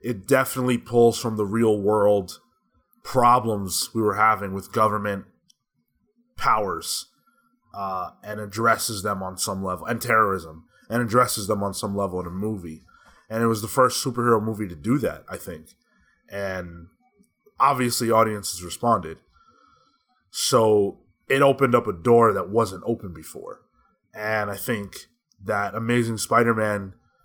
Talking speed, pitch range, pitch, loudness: 145 wpm, 100-120 Hz, 110 Hz, -23 LUFS